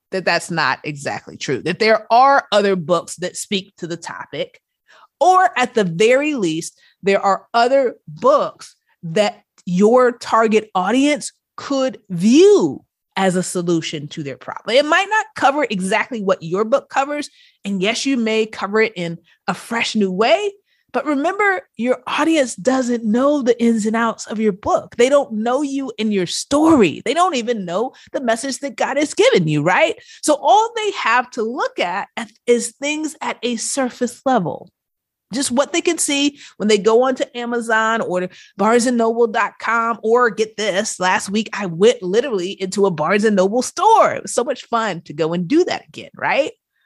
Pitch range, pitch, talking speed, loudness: 200-280 Hz, 230 Hz, 180 wpm, -17 LUFS